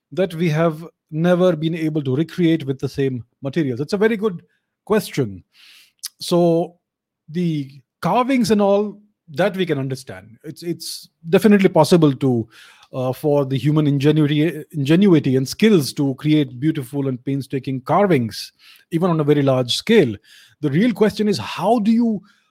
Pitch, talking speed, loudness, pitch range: 160 Hz, 155 wpm, -19 LUFS, 140-185 Hz